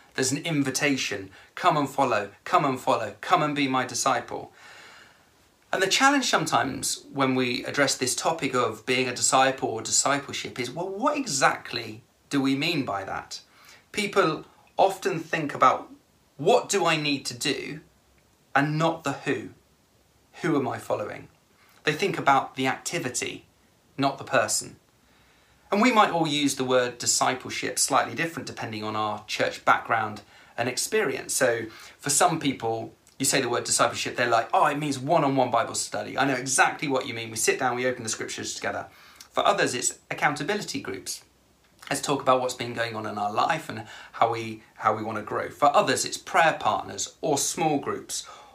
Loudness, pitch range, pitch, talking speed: -25 LUFS, 125-150 Hz, 135 Hz, 175 wpm